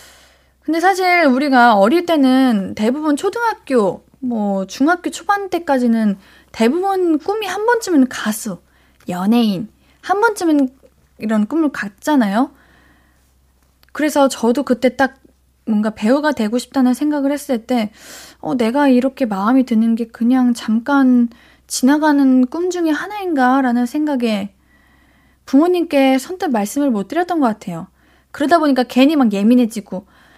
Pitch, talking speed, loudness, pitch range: 260 Hz, 280 characters per minute, -16 LUFS, 225-305 Hz